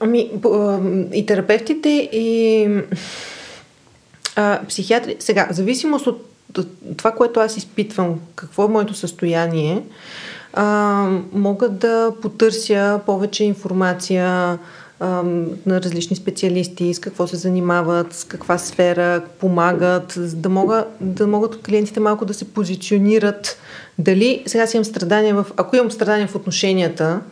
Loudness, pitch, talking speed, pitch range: -18 LUFS, 200 Hz, 125 wpm, 180-215 Hz